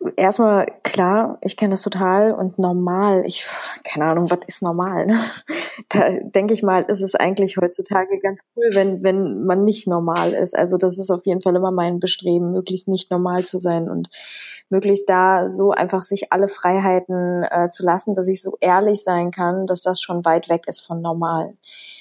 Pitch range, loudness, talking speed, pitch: 180-195 Hz, -19 LUFS, 190 wpm, 185 Hz